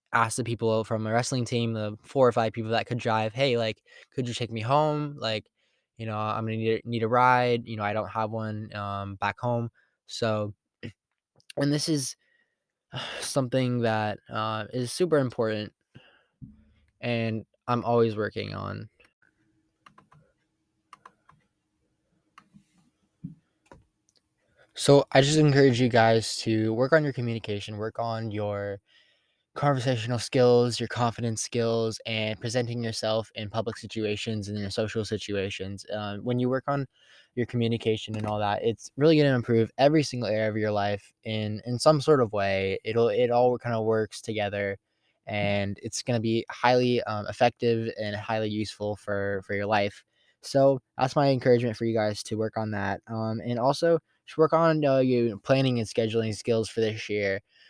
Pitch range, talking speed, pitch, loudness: 105-125 Hz, 165 wpm, 115 Hz, -27 LUFS